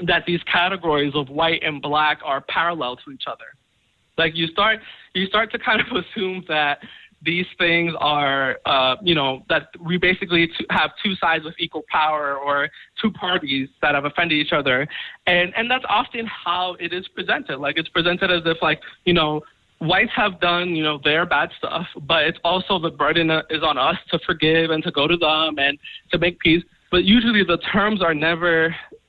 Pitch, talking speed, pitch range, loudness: 170 Hz, 195 wpm, 155-180 Hz, -20 LUFS